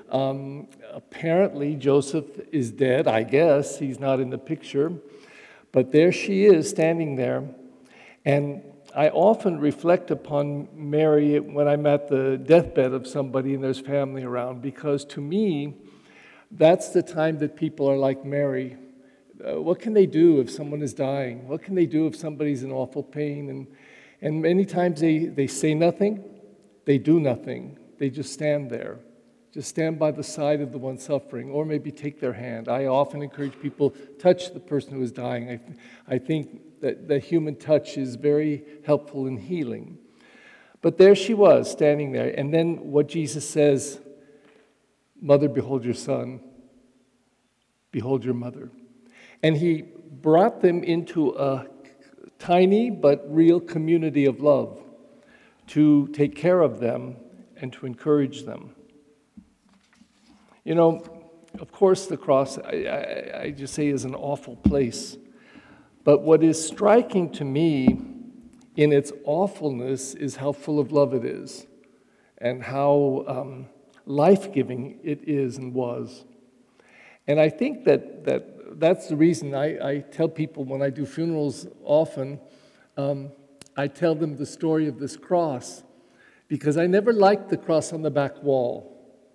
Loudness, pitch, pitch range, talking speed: -23 LUFS, 145 Hz, 135-165 Hz, 155 wpm